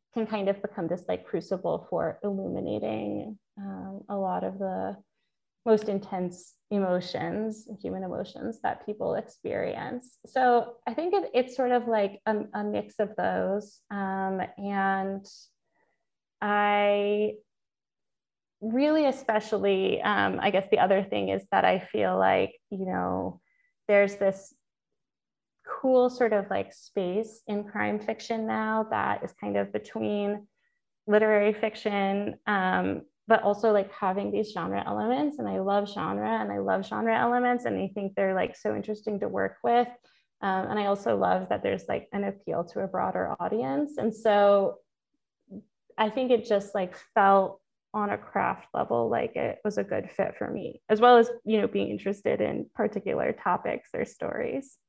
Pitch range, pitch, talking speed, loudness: 195-225 Hz, 205 Hz, 155 wpm, -28 LUFS